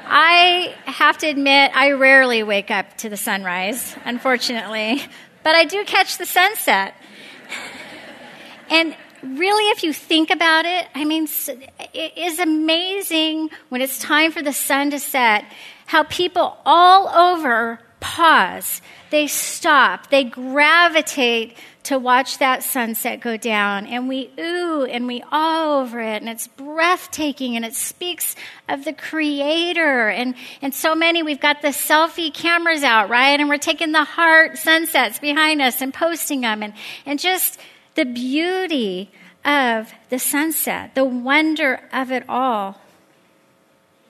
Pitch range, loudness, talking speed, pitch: 245-320 Hz, -17 LUFS, 145 wpm, 290 Hz